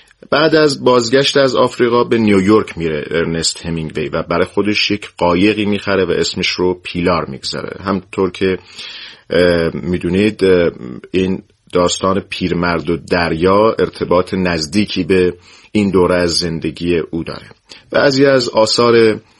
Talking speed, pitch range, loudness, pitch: 125 wpm, 90-110 Hz, -14 LUFS, 95 Hz